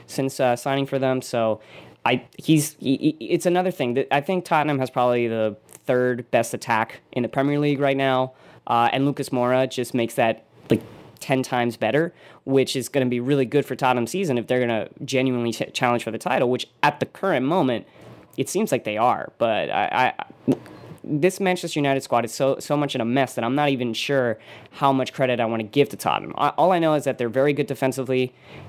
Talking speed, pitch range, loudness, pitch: 230 wpm, 125-145 Hz, -23 LUFS, 130 Hz